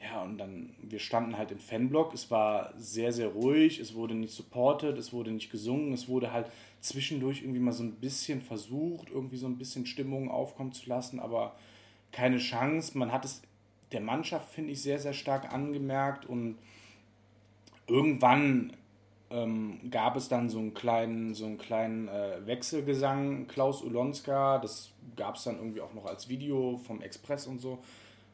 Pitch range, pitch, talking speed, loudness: 110-135 Hz, 125 Hz, 175 wpm, -33 LUFS